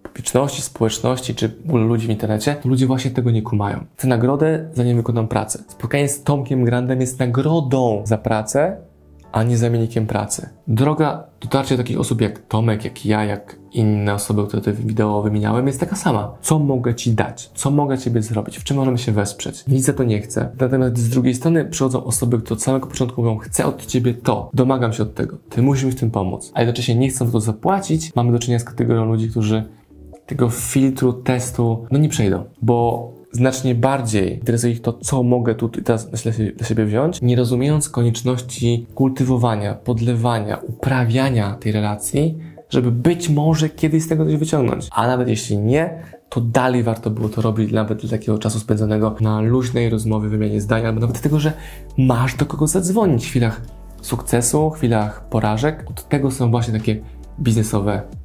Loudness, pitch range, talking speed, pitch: -19 LUFS, 110-130 Hz, 185 wpm, 120 Hz